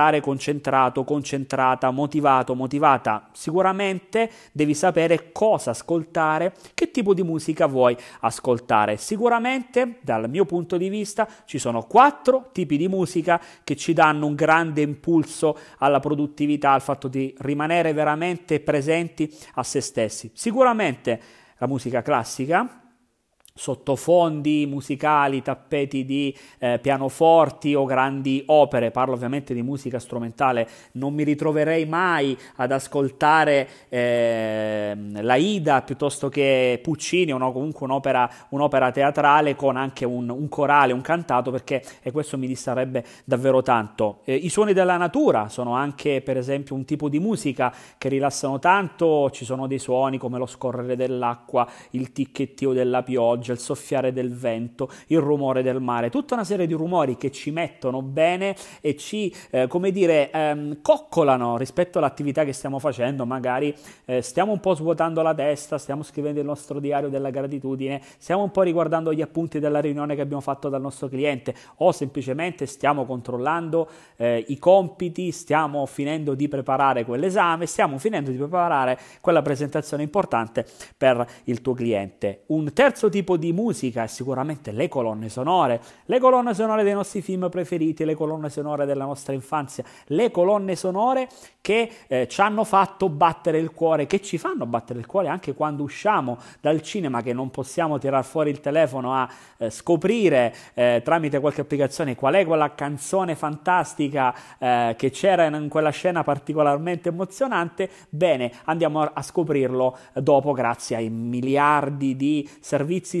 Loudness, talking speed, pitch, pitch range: -23 LUFS, 150 wpm, 145 Hz, 130-165 Hz